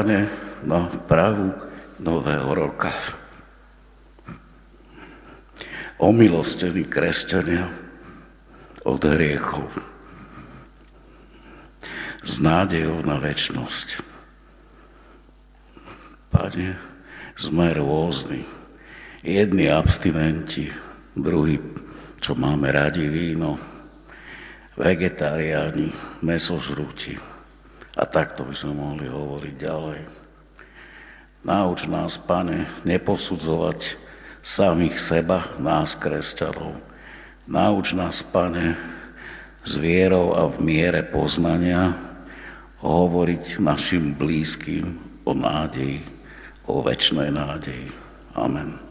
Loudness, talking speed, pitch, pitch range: -23 LUFS, 70 wpm, 85 Hz, 75-90 Hz